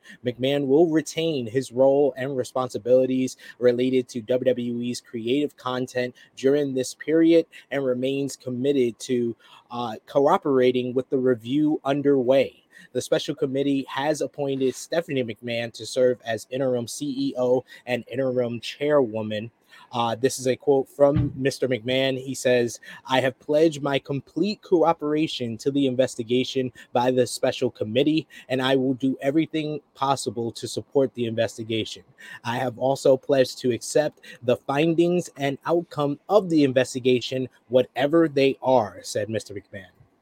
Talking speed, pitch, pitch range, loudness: 135 wpm, 130 Hz, 125-140 Hz, -24 LUFS